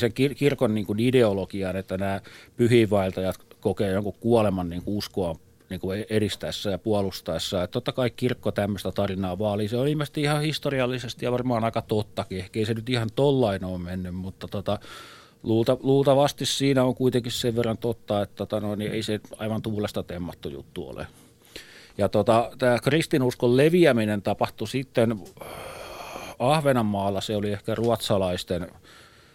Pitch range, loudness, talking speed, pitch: 100-125 Hz, -25 LUFS, 145 wpm, 110 Hz